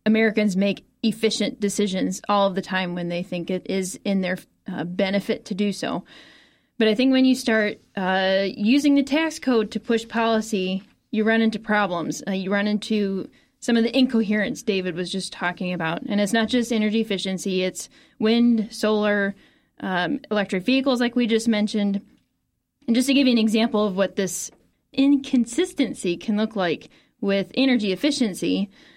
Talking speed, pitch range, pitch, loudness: 175 wpm, 195-235 Hz, 215 Hz, -23 LUFS